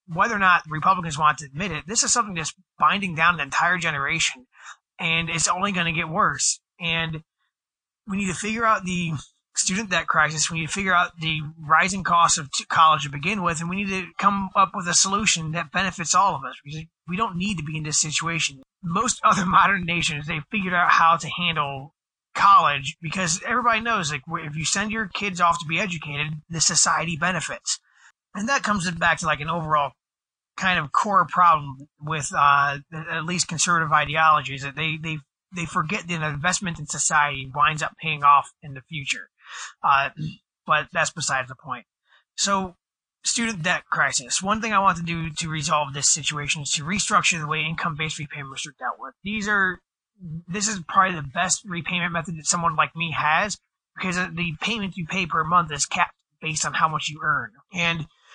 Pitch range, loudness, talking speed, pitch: 155-185 Hz, -22 LUFS, 195 wpm, 165 Hz